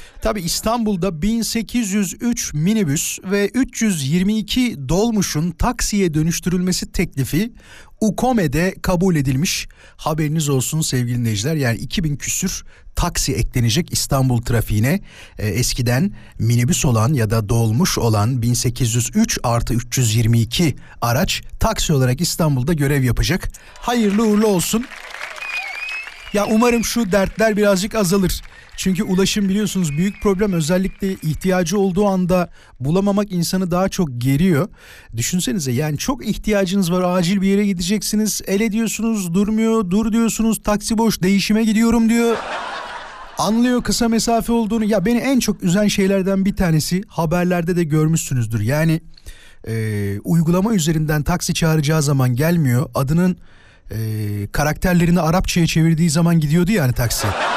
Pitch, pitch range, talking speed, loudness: 180 Hz, 135-210 Hz, 120 wpm, -18 LUFS